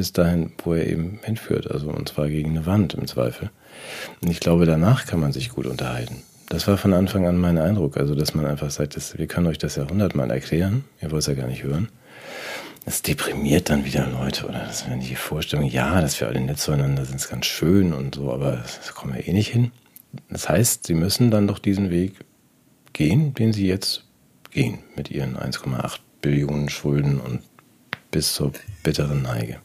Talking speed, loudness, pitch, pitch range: 205 wpm, -23 LUFS, 80 Hz, 70-95 Hz